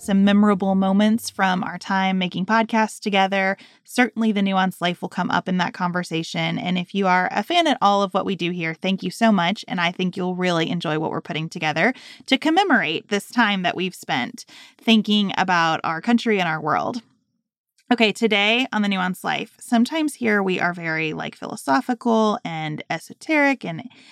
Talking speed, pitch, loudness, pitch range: 190 wpm, 200 Hz, -21 LUFS, 180-230 Hz